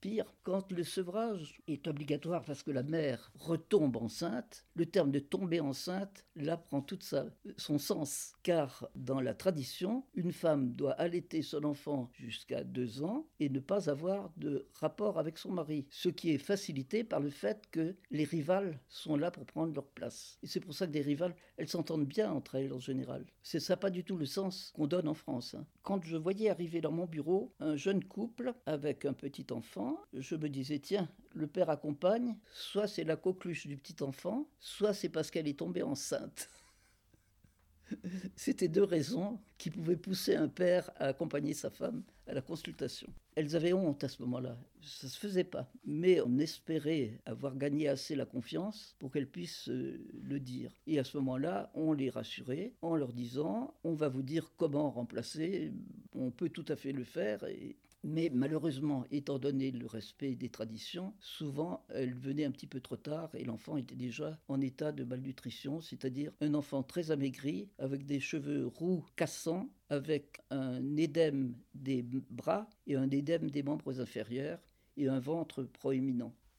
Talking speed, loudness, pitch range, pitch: 180 wpm, -37 LUFS, 135-180 Hz, 150 Hz